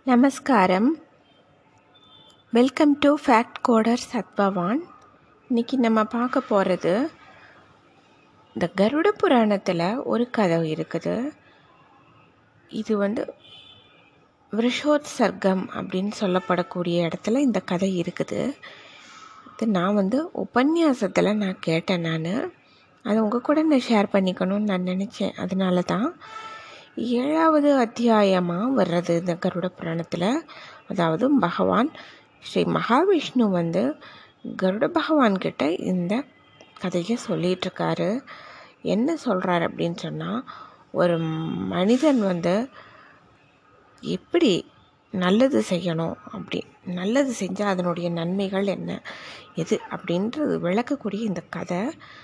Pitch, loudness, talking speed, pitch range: 210 Hz, -23 LUFS, 90 wpm, 185-265 Hz